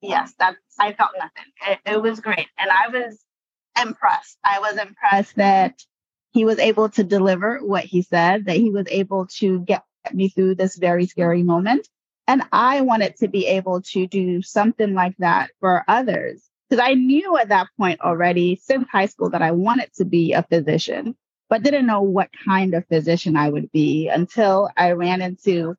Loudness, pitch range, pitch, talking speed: -19 LUFS, 180-215 Hz, 195 Hz, 190 wpm